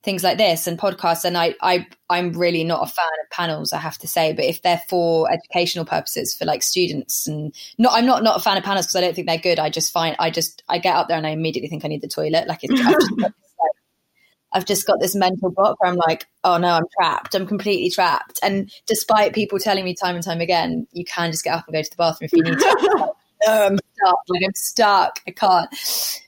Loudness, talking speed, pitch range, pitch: -19 LUFS, 265 wpm, 165-200 Hz, 175 Hz